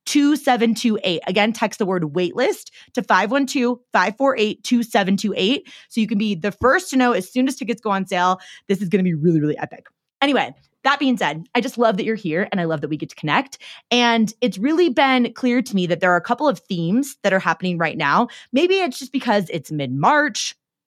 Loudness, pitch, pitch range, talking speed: -20 LUFS, 220 Hz, 185-255 Hz, 220 wpm